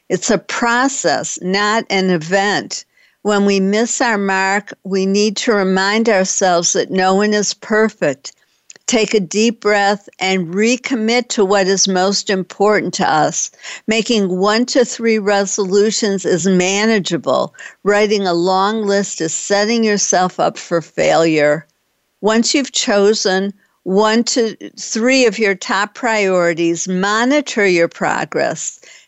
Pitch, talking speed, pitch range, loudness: 205 Hz, 130 wpm, 190-220 Hz, -15 LUFS